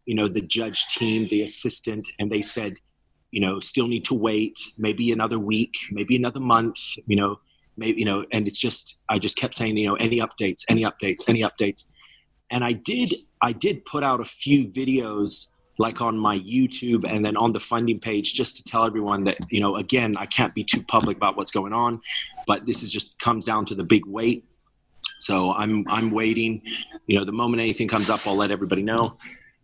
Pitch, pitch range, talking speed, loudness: 110 Hz, 105-115 Hz, 210 wpm, -23 LUFS